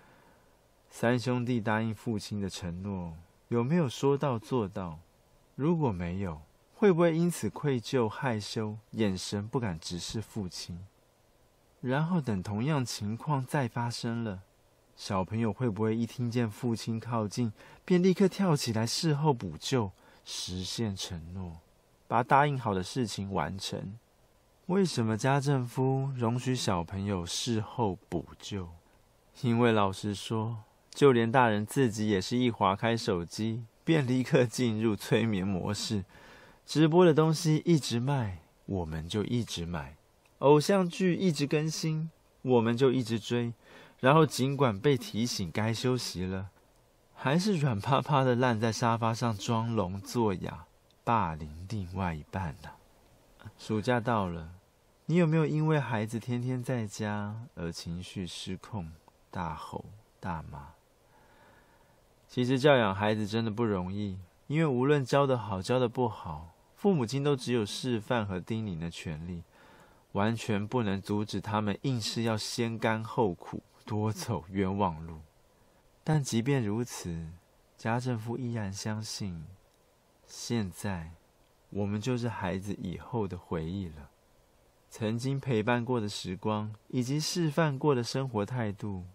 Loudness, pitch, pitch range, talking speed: -31 LUFS, 115 Hz, 100-130 Hz, 210 characters per minute